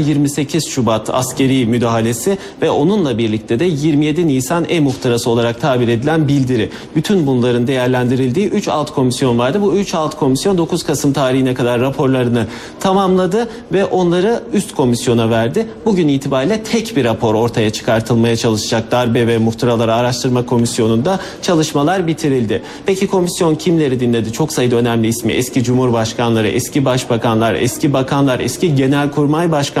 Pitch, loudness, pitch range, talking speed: 130 Hz, -15 LUFS, 120-160 Hz, 140 wpm